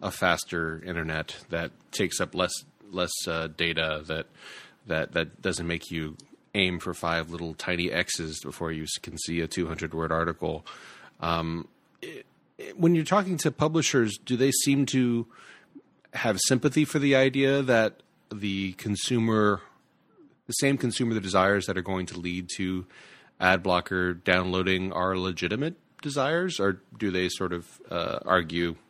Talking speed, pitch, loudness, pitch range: 155 wpm, 95 Hz, -27 LUFS, 85-120 Hz